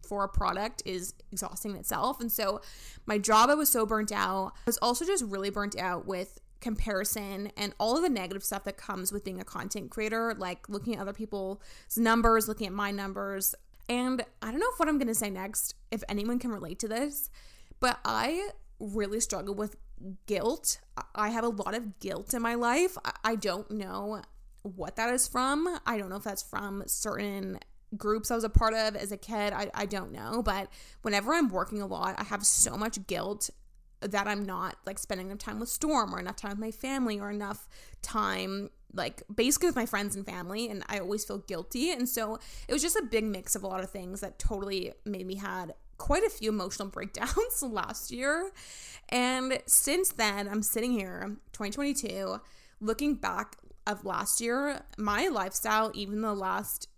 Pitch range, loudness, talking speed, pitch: 200-230 Hz, -31 LUFS, 200 wpm, 210 Hz